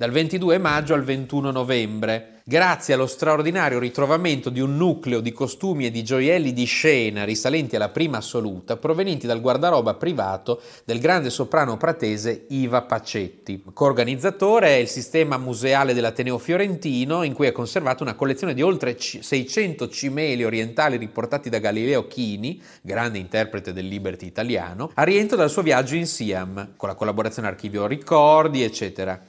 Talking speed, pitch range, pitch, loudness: 150 wpm, 115-155 Hz, 130 Hz, -22 LUFS